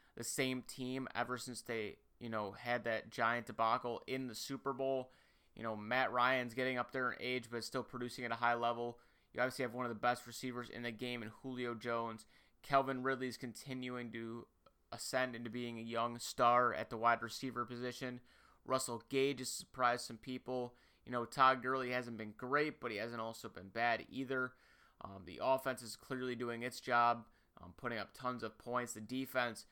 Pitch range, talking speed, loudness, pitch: 120-130 Hz, 195 wpm, -39 LUFS, 125 Hz